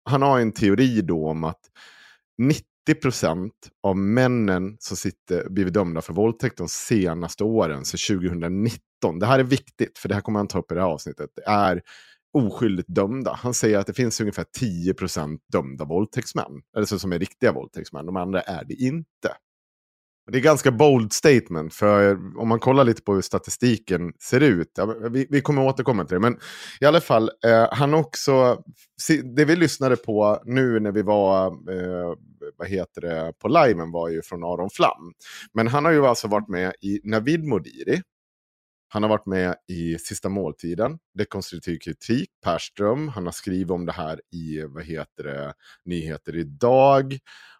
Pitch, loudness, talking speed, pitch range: 105 Hz, -22 LUFS, 175 wpm, 90-125 Hz